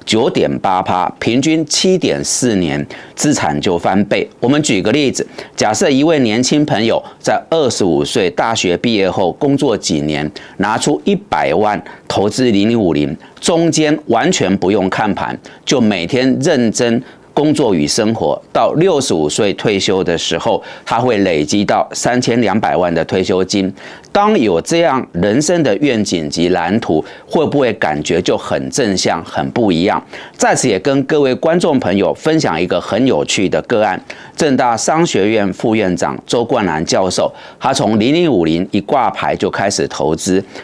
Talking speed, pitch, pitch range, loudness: 250 characters per minute, 115 Hz, 90-145 Hz, -14 LUFS